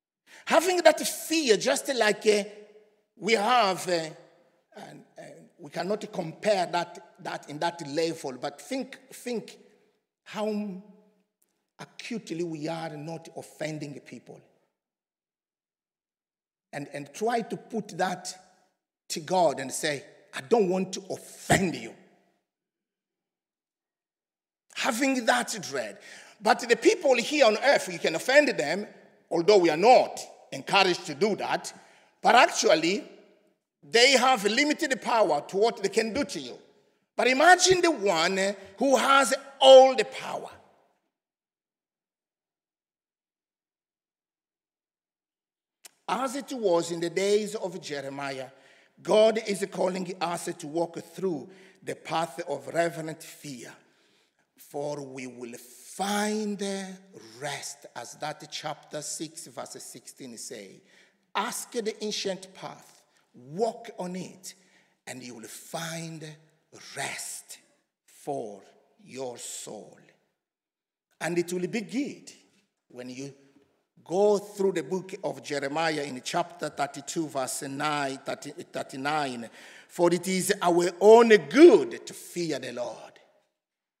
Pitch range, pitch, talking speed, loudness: 160-220 Hz, 185 Hz, 120 wpm, -26 LUFS